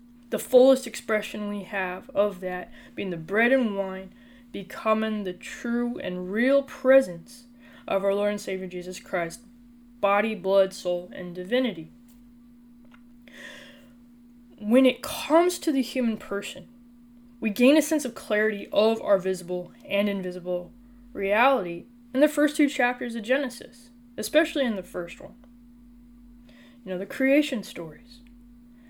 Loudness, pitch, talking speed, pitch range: -25 LUFS, 240 Hz, 135 wpm, 200-245 Hz